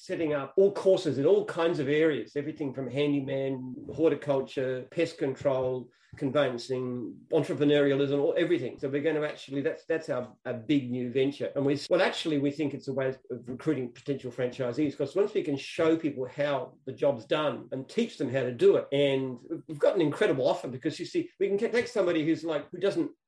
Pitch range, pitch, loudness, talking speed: 135-160 Hz, 145 Hz, -29 LUFS, 200 wpm